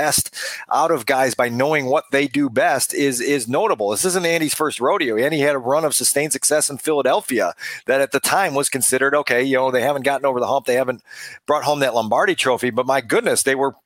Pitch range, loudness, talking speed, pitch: 130-145 Hz, -18 LUFS, 230 wpm, 140 Hz